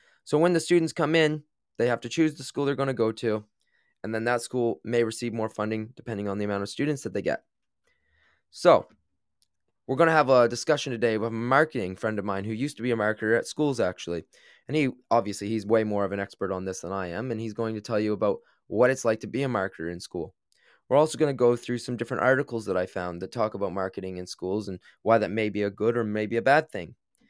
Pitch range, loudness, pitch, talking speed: 105-130 Hz, -27 LUFS, 115 Hz, 255 wpm